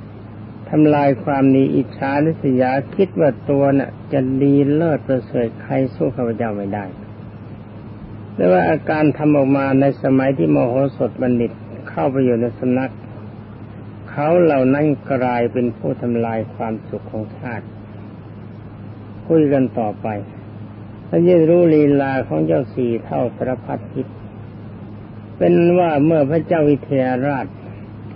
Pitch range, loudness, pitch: 105-140 Hz, -17 LUFS, 120 Hz